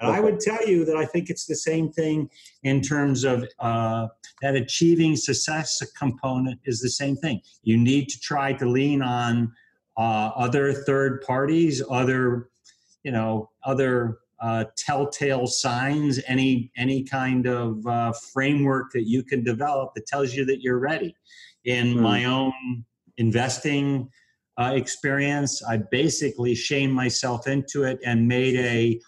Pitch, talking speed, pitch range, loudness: 130 Hz, 150 wpm, 120-140 Hz, -24 LUFS